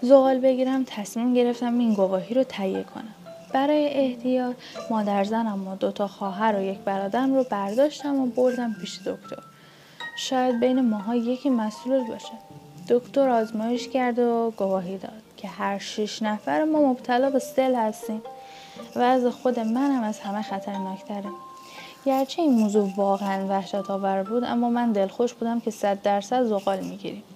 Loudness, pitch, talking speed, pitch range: -25 LUFS, 230 Hz, 160 wpm, 200-255 Hz